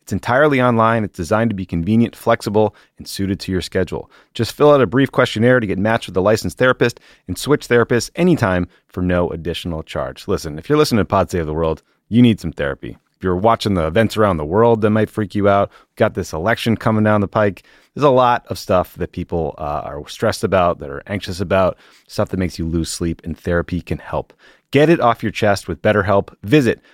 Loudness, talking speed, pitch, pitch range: -17 LUFS, 225 wpm, 105 Hz, 90-115 Hz